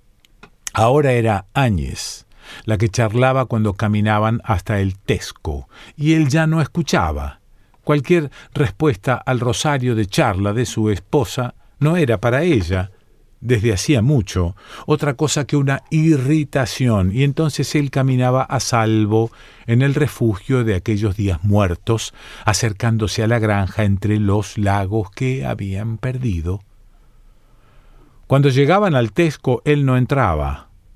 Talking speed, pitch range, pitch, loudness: 130 wpm, 105-140 Hz, 115 Hz, -18 LUFS